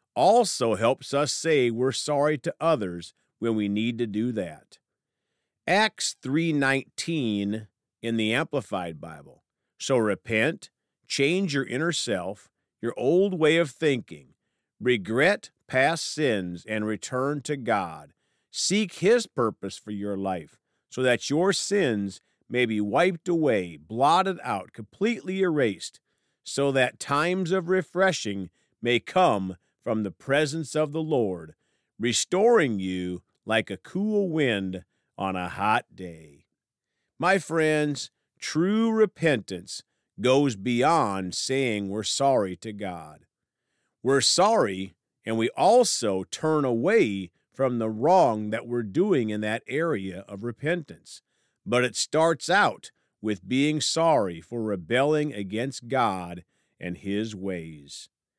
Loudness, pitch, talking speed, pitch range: -25 LUFS, 125 Hz, 125 wpm, 100-155 Hz